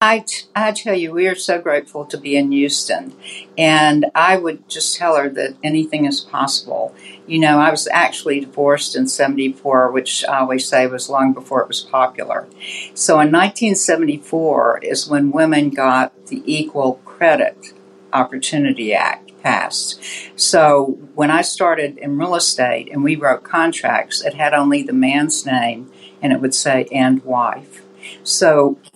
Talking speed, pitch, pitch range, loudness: 160 wpm, 145 Hz, 130-160 Hz, -16 LUFS